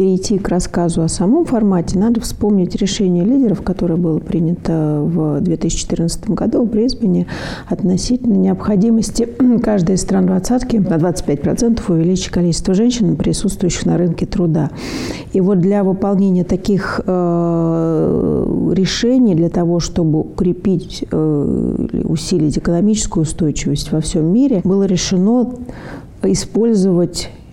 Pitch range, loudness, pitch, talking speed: 170-210 Hz, -15 LUFS, 185 Hz, 115 wpm